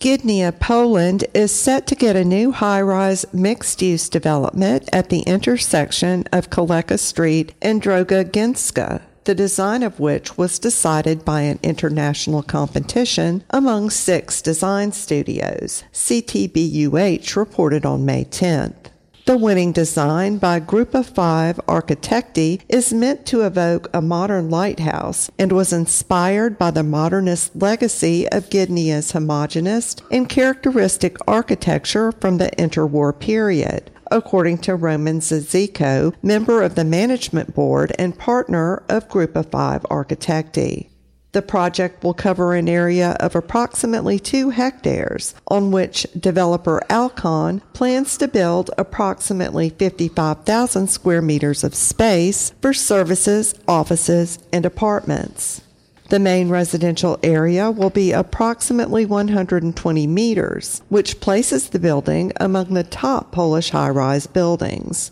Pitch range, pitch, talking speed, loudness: 165-205 Hz, 180 Hz, 125 wpm, -18 LUFS